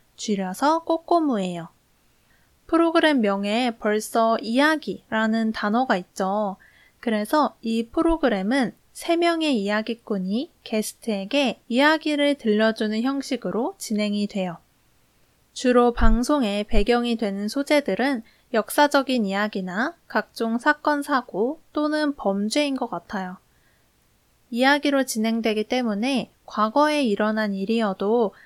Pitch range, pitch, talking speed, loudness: 210-280 Hz, 230 Hz, 260 characters per minute, -23 LUFS